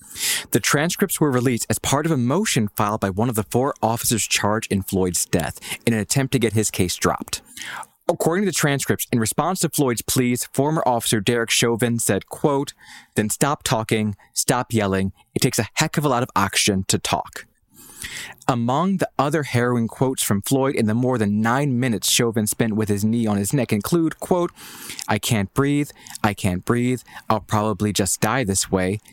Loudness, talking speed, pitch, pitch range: -21 LUFS, 195 wpm, 120 Hz, 105-140 Hz